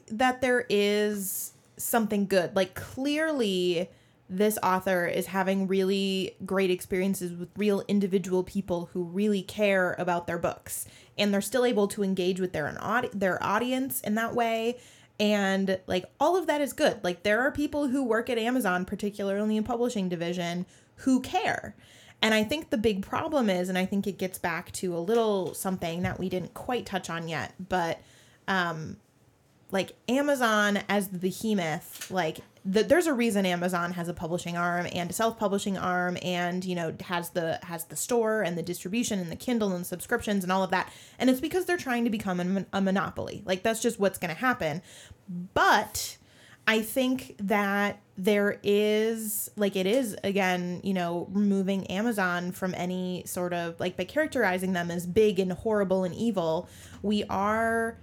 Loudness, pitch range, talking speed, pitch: -28 LUFS, 180-220 Hz, 180 wpm, 195 Hz